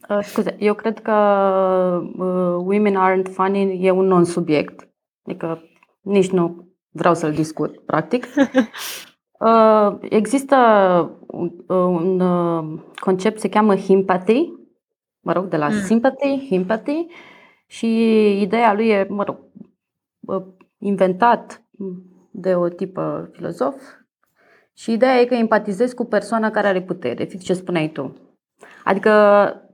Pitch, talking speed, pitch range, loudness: 195 Hz, 125 wpm, 180-220 Hz, -18 LUFS